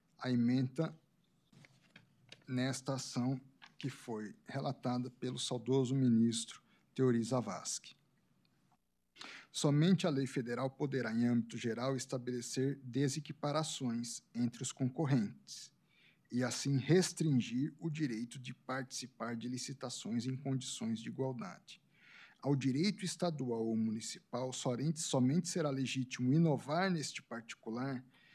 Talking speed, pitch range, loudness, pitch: 105 wpm, 125-150 Hz, -37 LUFS, 130 Hz